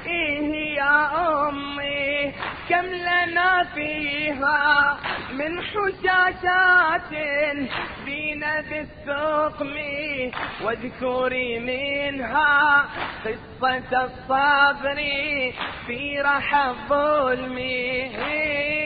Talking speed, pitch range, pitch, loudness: 55 wpm, 275-305 Hz, 285 Hz, -22 LUFS